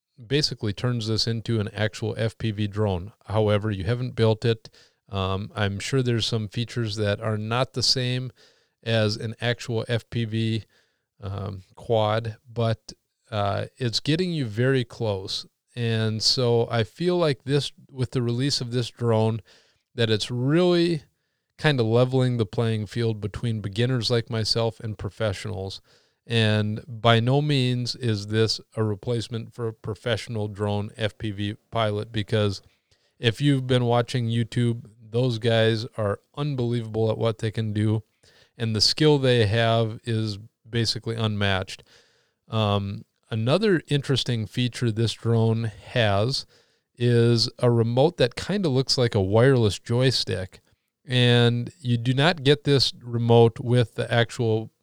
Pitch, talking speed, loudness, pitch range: 115 Hz, 140 wpm, -24 LUFS, 110-125 Hz